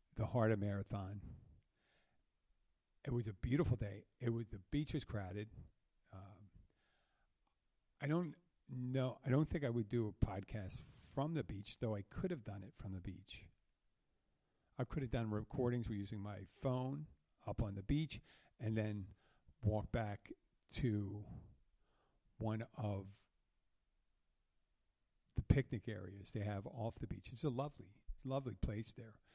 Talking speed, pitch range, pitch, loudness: 145 wpm, 100-125 Hz, 110 Hz, -43 LUFS